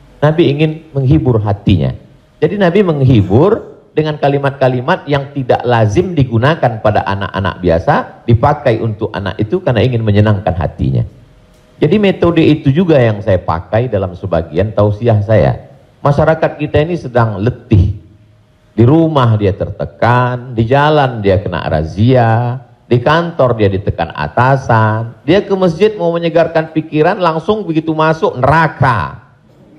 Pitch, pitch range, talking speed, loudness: 125 Hz, 105-155 Hz, 130 wpm, -12 LUFS